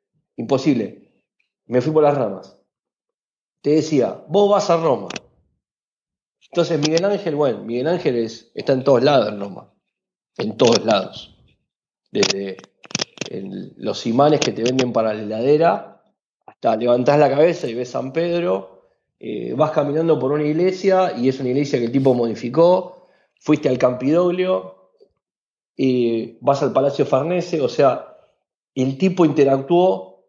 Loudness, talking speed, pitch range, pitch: -19 LUFS, 145 wpm, 120-170 Hz, 145 Hz